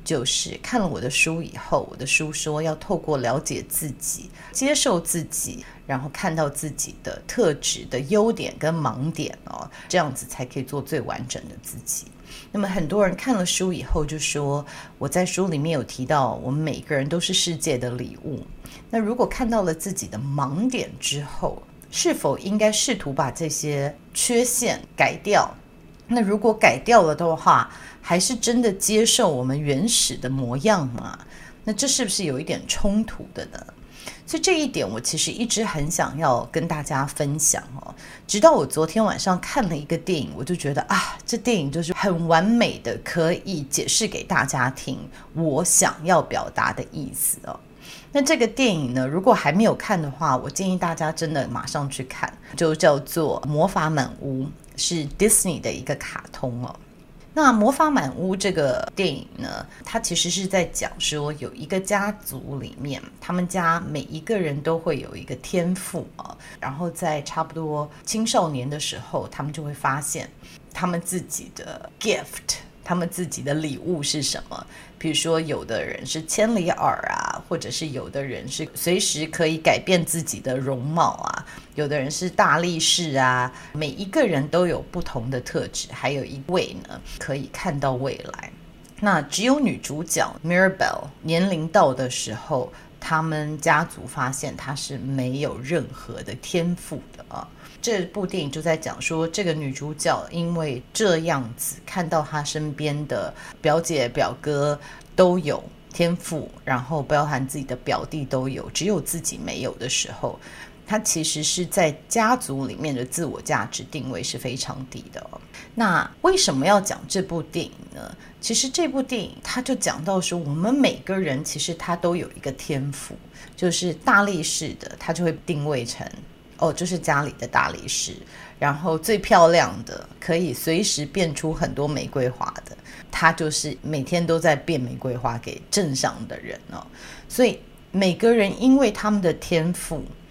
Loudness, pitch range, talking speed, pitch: -23 LUFS, 145-185 Hz, 260 characters per minute, 160 Hz